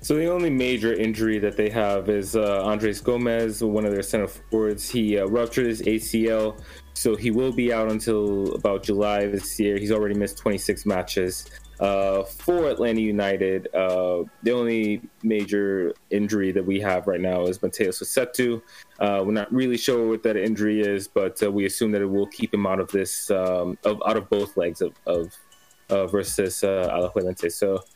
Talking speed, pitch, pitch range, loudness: 190 wpm, 105 Hz, 95-110 Hz, -24 LUFS